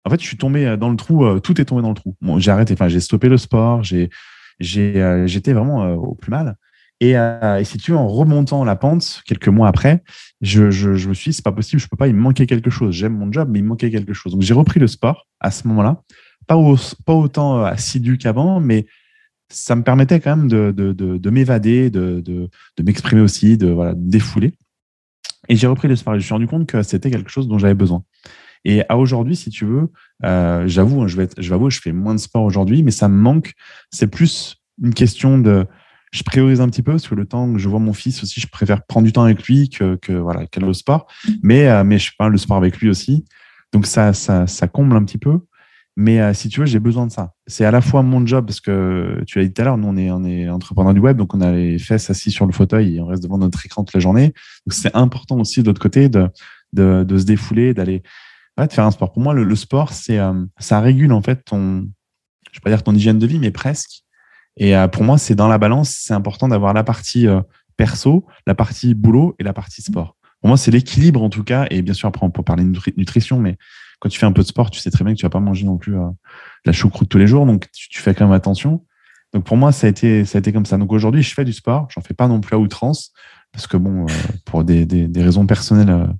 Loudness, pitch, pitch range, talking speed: -15 LUFS, 110 Hz, 95-130 Hz, 275 wpm